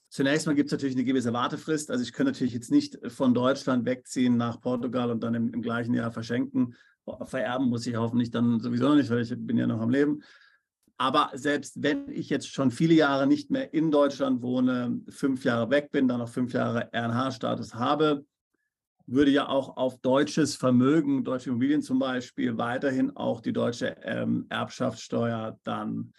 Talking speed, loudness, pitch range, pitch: 185 wpm, -27 LUFS, 120-145 Hz, 130 Hz